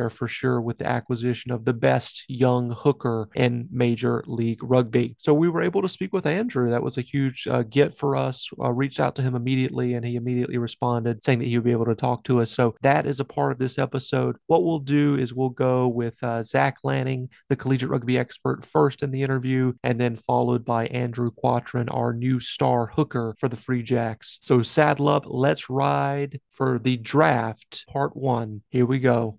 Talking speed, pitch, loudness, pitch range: 210 wpm, 125 Hz, -24 LUFS, 120-135 Hz